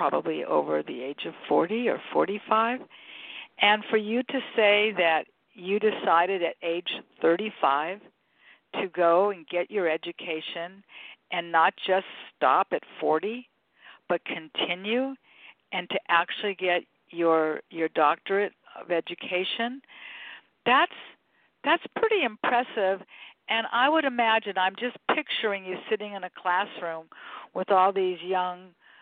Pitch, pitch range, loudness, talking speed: 190 Hz, 175-220 Hz, -26 LUFS, 130 wpm